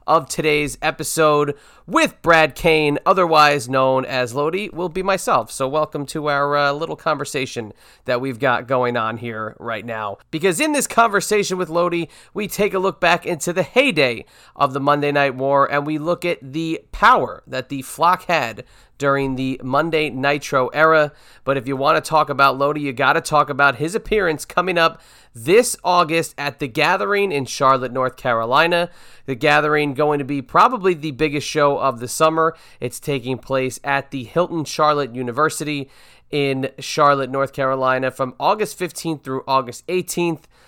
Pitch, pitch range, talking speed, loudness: 145 Hz, 135-165 Hz, 175 wpm, -19 LUFS